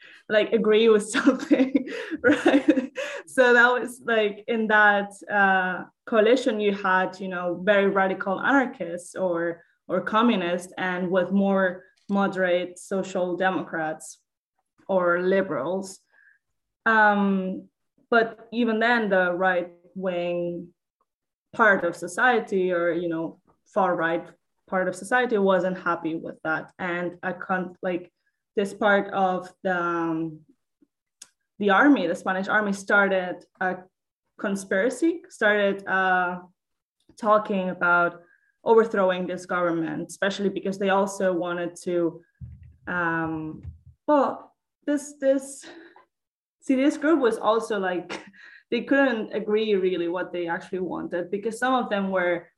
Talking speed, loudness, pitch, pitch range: 120 wpm, -24 LUFS, 195 Hz, 180-230 Hz